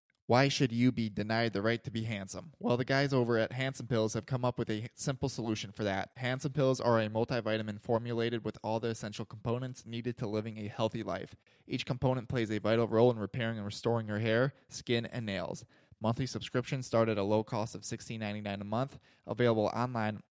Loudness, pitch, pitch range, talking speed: -33 LUFS, 115 Hz, 110-125 Hz, 215 wpm